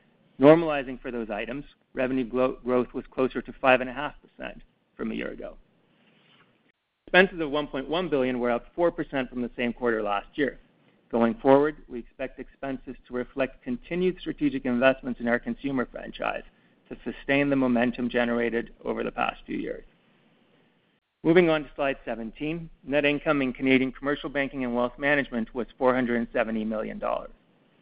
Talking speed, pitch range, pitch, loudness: 145 wpm, 120-145 Hz, 130 Hz, -26 LUFS